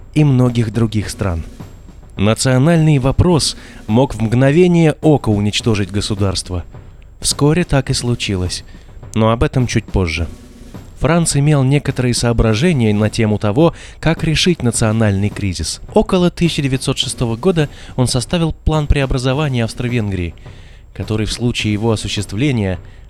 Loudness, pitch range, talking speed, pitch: -15 LUFS, 100-135 Hz, 115 wpm, 120 Hz